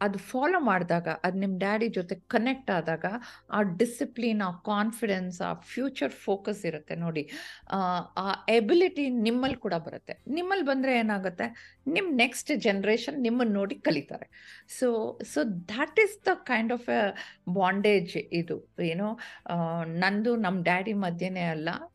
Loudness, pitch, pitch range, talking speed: -29 LUFS, 215 Hz, 185-245 Hz, 130 wpm